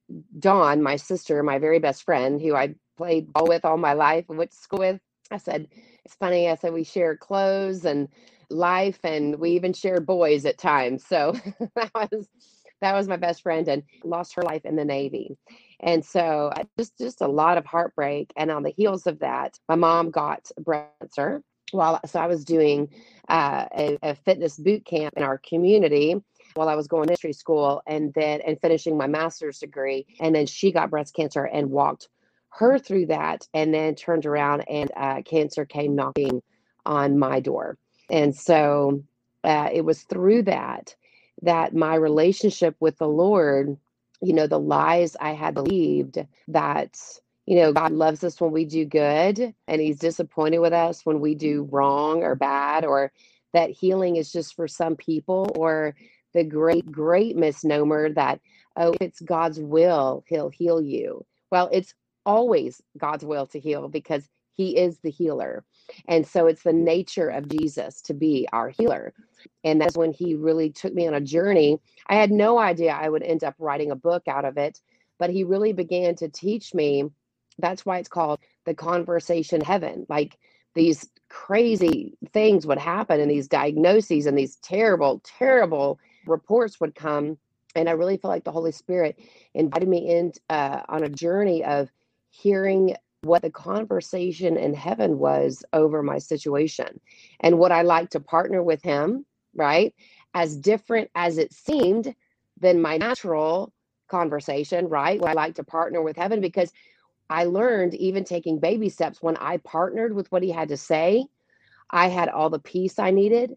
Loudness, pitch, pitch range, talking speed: -23 LUFS, 165 Hz, 150-180 Hz, 180 wpm